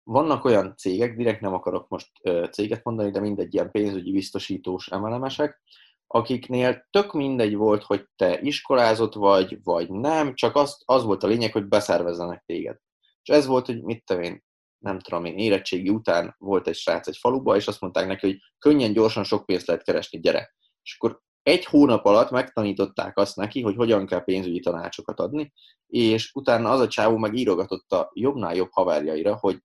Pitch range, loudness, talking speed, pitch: 95-125 Hz, -23 LUFS, 180 wpm, 110 Hz